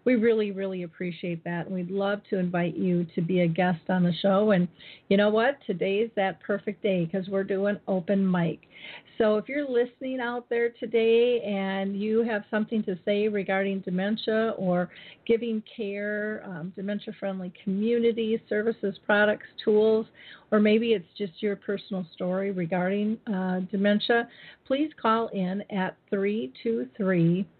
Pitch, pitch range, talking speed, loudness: 205 Hz, 185-220 Hz, 155 wpm, -27 LUFS